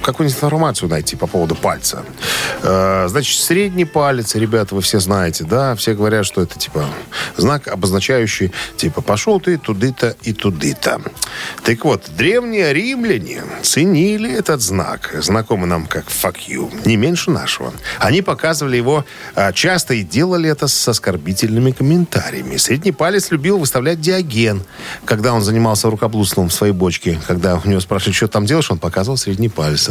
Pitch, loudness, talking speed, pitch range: 115 Hz, -16 LUFS, 150 wpm, 95-160 Hz